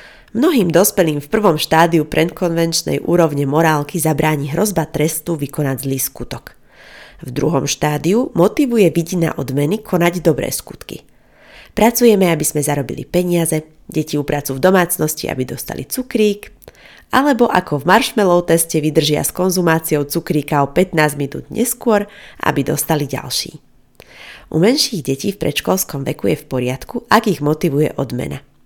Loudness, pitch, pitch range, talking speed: -16 LUFS, 160 Hz, 150-185 Hz, 135 wpm